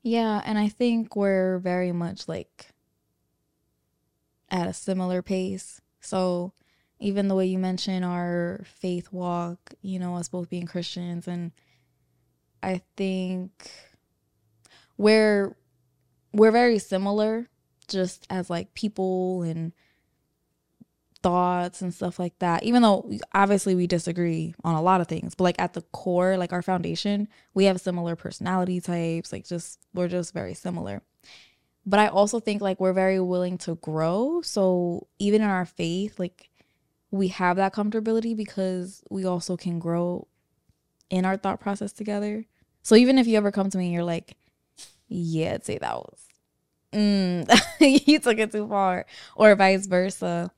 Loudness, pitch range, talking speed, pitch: -25 LUFS, 175-200 Hz, 150 wpm, 185 Hz